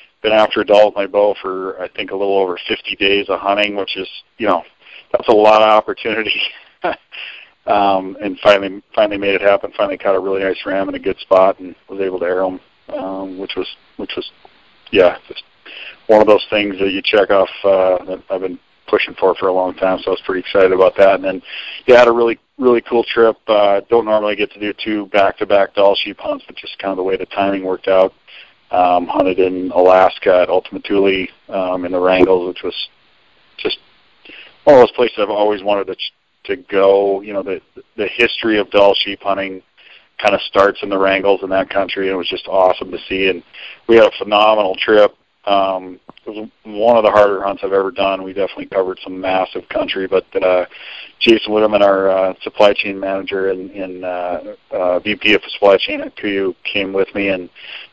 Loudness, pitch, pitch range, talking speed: -15 LUFS, 95 Hz, 95-105 Hz, 215 wpm